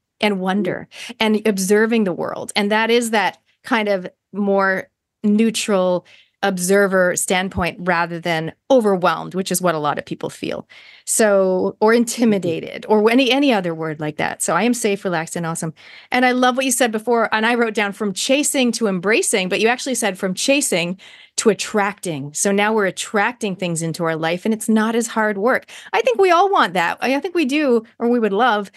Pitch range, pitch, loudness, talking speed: 185-235 Hz, 210 Hz, -18 LUFS, 200 wpm